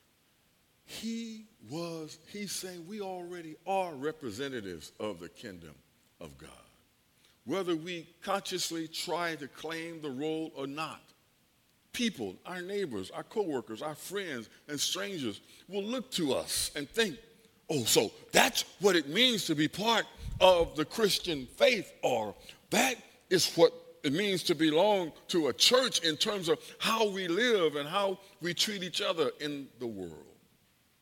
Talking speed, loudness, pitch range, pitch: 150 wpm, -31 LUFS, 155-205 Hz, 175 Hz